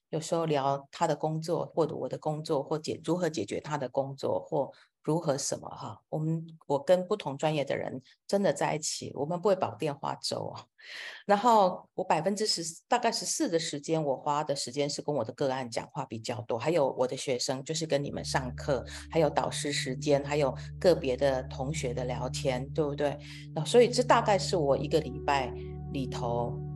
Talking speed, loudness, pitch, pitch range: 290 characters per minute, -30 LUFS, 145 Hz, 135-165 Hz